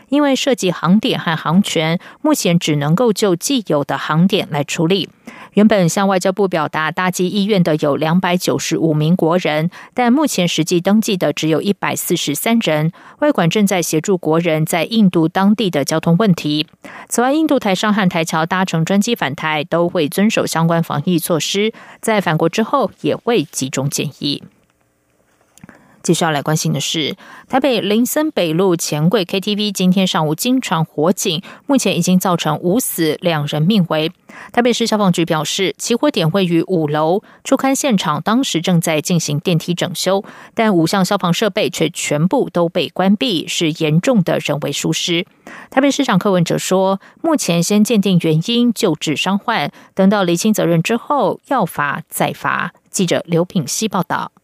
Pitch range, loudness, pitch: 160-210 Hz, -16 LUFS, 180 Hz